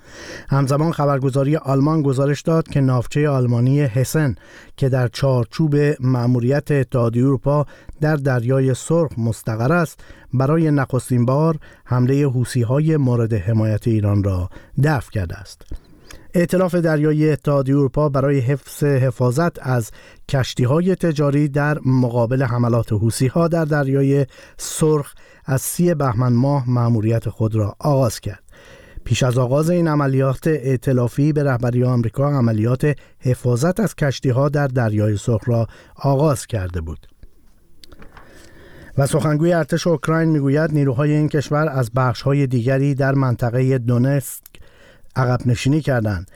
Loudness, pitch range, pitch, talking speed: -18 LUFS, 120-150 Hz, 135 Hz, 125 wpm